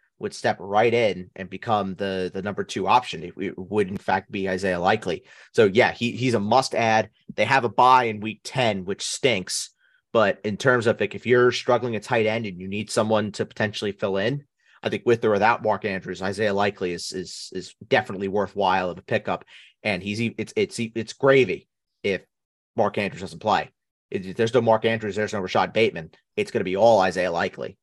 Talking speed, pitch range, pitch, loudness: 210 wpm, 95-115 Hz, 105 Hz, -23 LUFS